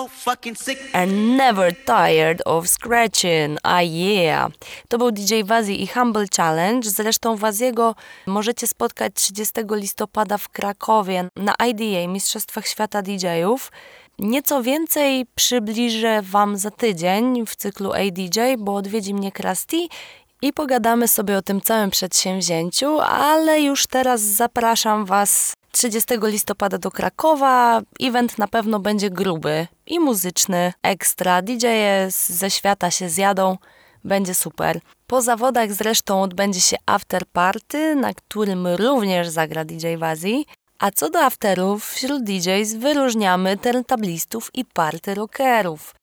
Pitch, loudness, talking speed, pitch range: 215 Hz, -19 LUFS, 125 wpm, 190-245 Hz